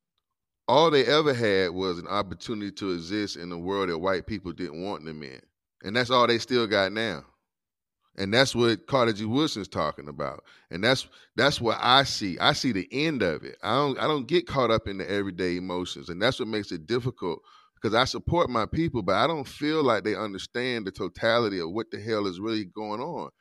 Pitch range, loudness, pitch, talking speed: 95-120 Hz, -26 LUFS, 105 Hz, 220 wpm